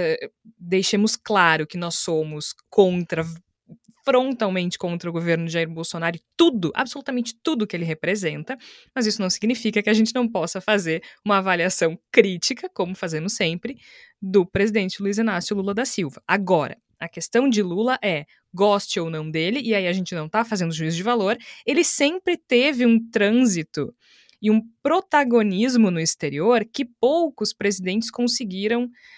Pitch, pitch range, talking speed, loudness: 205 Hz, 175-240 Hz, 160 wpm, -22 LUFS